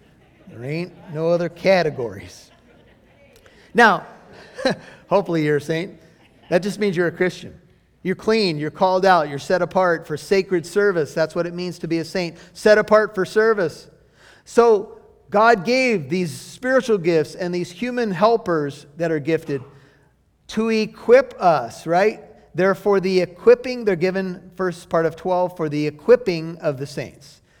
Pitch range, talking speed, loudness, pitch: 165-210 Hz, 155 wpm, -20 LUFS, 180 Hz